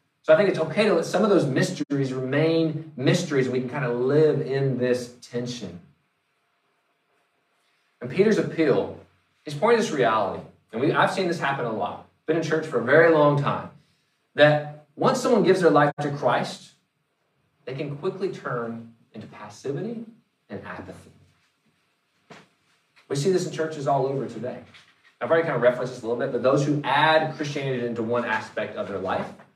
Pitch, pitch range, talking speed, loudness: 145 Hz, 125-160 Hz, 185 wpm, -23 LUFS